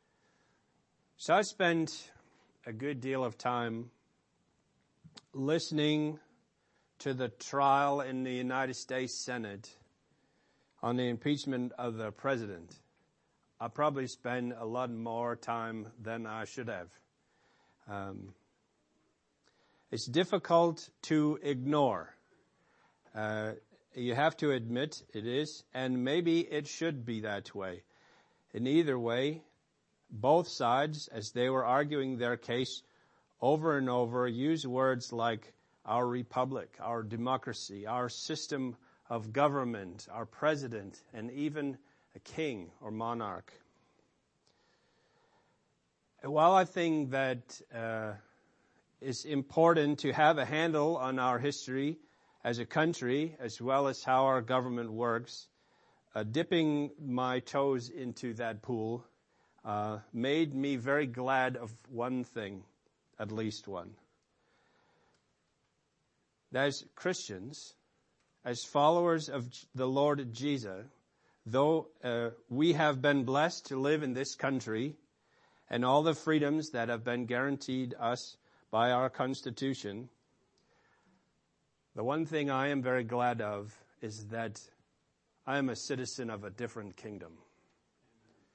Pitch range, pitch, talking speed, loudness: 115-145 Hz, 130 Hz, 120 wpm, -33 LUFS